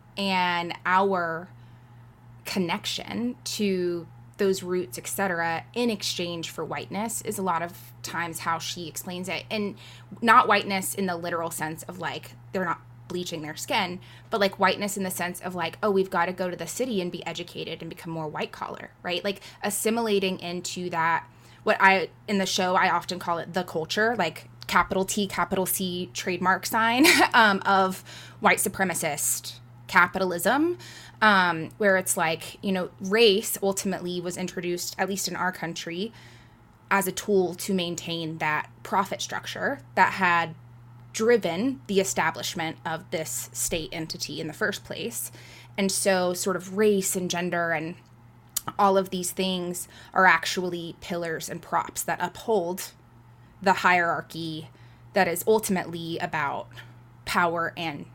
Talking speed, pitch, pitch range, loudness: 155 wpm, 175 Hz, 160-195 Hz, -26 LUFS